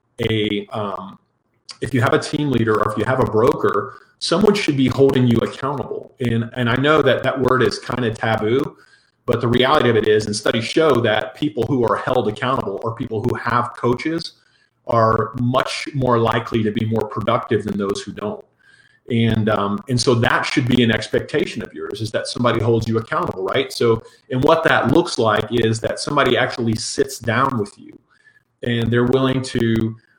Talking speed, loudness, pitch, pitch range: 195 wpm, -19 LUFS, 120 Hz, 110-130 Hz